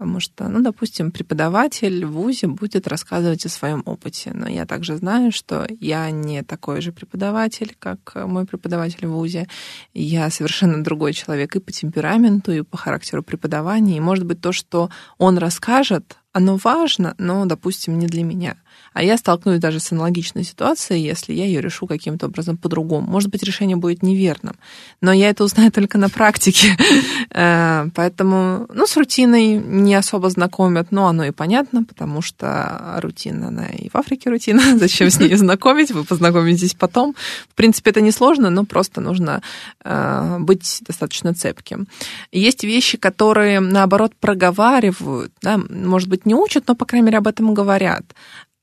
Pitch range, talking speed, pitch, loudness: 170-215 Hz, 160 wpm, 190 Hz, -17 LUFS